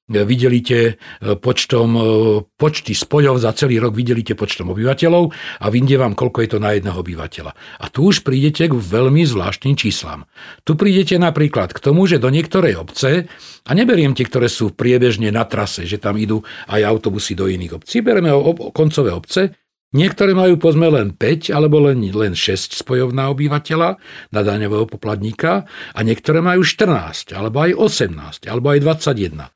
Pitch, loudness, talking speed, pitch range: 125 Hz, -16 LUFS, 165 wpm, 105-155 Hz